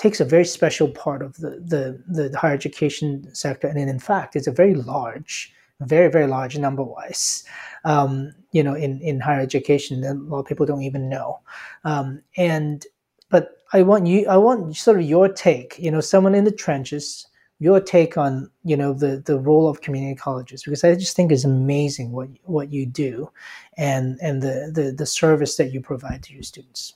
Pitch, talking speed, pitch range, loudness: 145 Hz, 200 wpm, 135-165 Hz, -20 LUFS